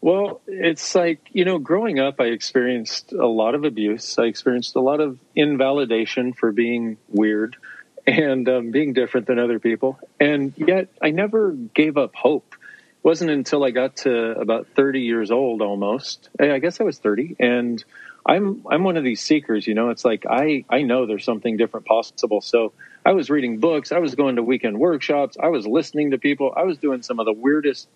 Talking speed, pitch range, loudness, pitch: 195 wpm, 115-150 Hz, -20 LUFS, 135 Hz